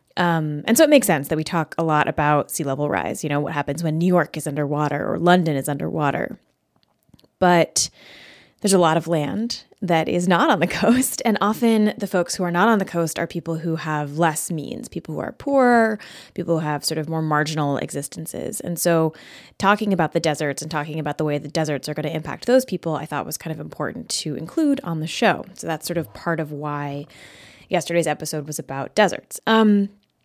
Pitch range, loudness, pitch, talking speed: 150-185 Hz, -21 LUFS, 165 Hz, 220 wpm